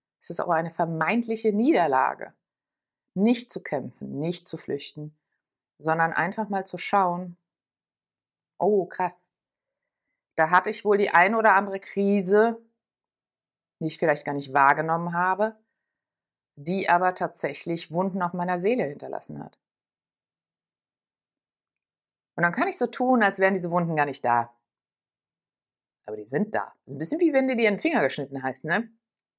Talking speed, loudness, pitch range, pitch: 150 wpm, -25 LUFS, 160-215 Hz, 180 Hz